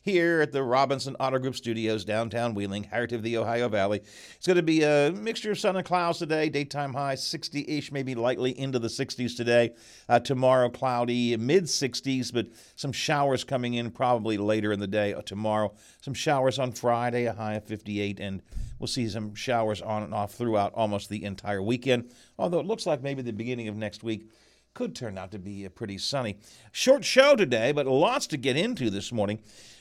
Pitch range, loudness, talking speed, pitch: 105-135 Hz, -27 LUFS, 200 wpm, 120 Hz